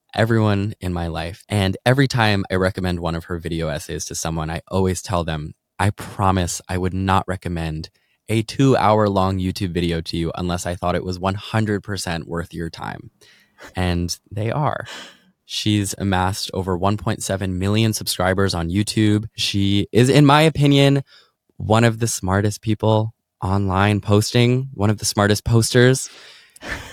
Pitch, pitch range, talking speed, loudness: 100 Hz, 90-110 Hz, 160 wpm, -20 LUFS